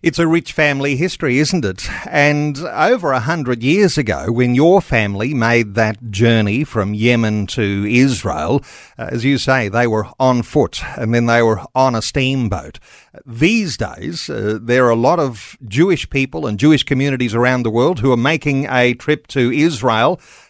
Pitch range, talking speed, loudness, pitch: 115-145 Hz, 175 wpm, -15 LUFS, 125 Hz